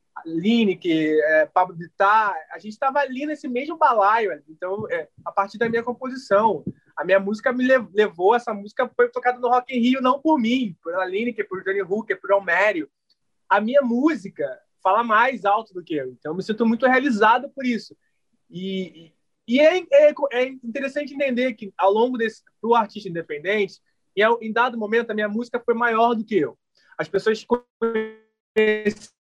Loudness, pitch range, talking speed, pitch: -21 LUFS, 195-250 Hz, 185 wpm, 225 Hz